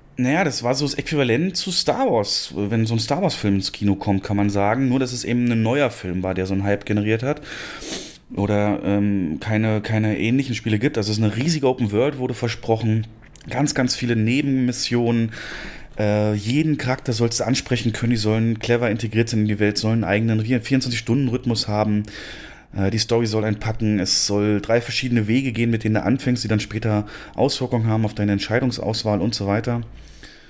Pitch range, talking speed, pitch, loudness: 105-125 Hz, 195 wpm, 115 Hz, -21 LUFS